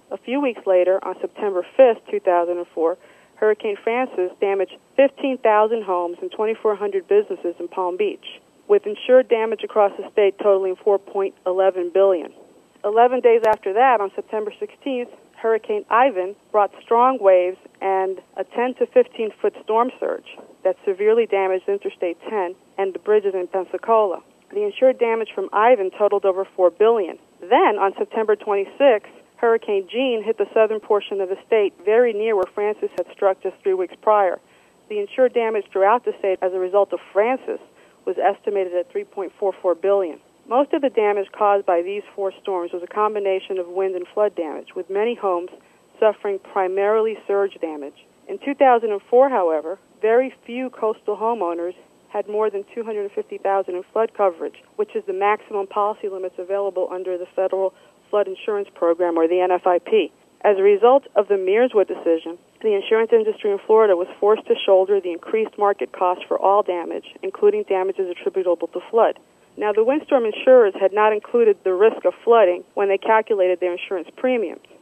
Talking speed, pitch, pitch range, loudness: 165 wpm, 205 Hz, 190-255 Hz, -20 LUFS